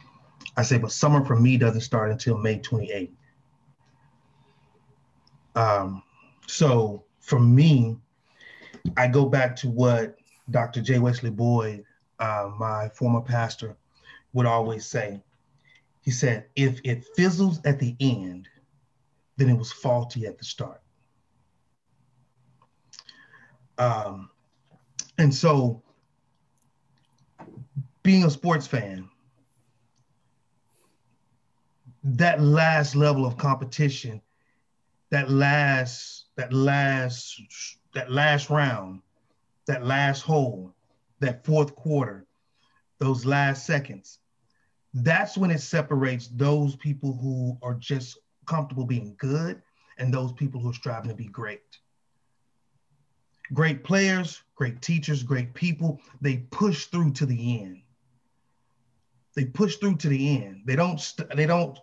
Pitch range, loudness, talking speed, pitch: 120-145 Hz, -24 LUFS, 115 wpm, 130 Hz